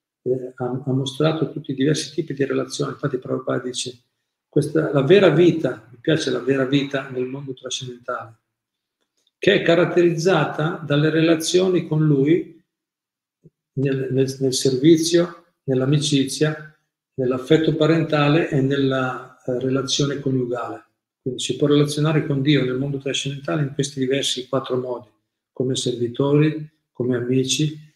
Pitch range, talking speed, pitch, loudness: 130-155 Hz, 135 wpm, 140 Hz, -20 LUFS